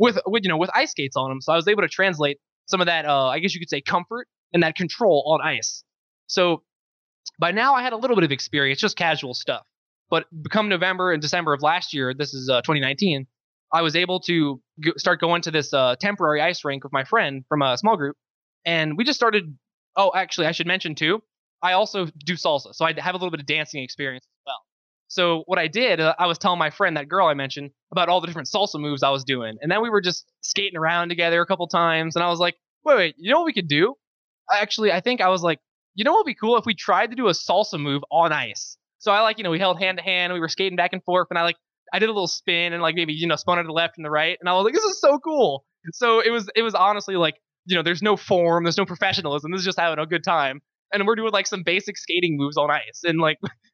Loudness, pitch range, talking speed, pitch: -22 LUFS, 155-195 Hz, 275 wpm, 170 Hz